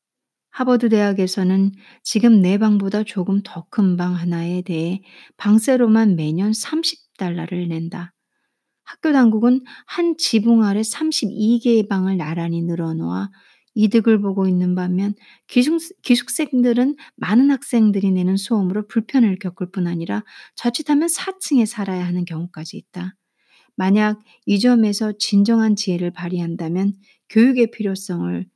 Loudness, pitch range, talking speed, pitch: -19 LUFS, 180-235 Hz, 280 characters per minute, 205 Hz